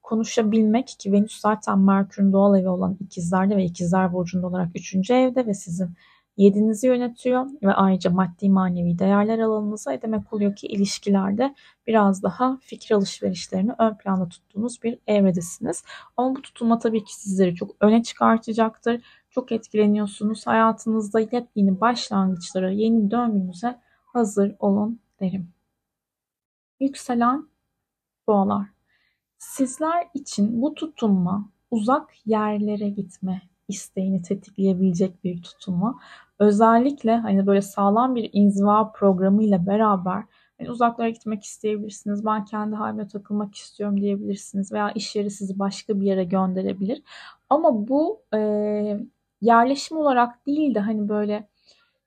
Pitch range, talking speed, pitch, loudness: 195-230 Hz, 120 wpm, 210 Hz, -22 LUFS